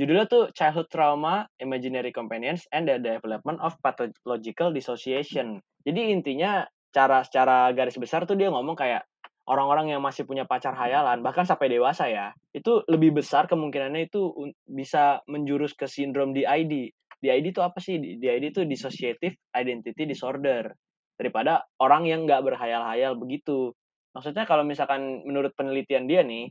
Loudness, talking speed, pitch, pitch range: -26 LUFS, 145 wpm, 140 Hz, 130-160 Hz